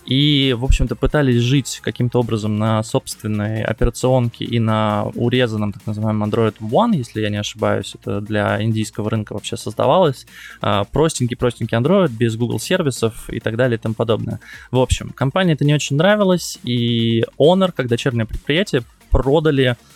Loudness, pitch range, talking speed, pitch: -18 LUFS, 110-130 Hz, 155 wpm, 115 Hz